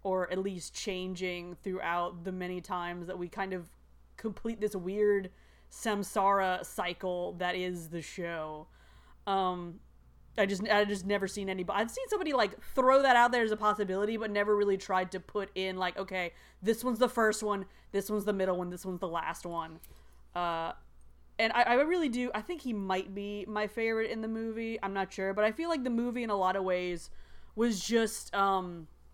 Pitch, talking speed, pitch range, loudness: 195 Hz, 200 wpm, 180-215 Hz, -32 LUFS